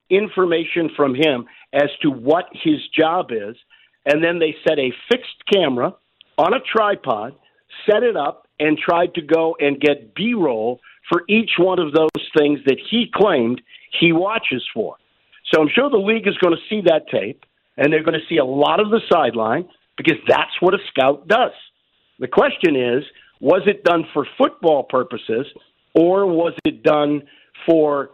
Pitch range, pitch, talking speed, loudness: 150-190 Hz, 165 Hz, 175 wpm, -18 LUFS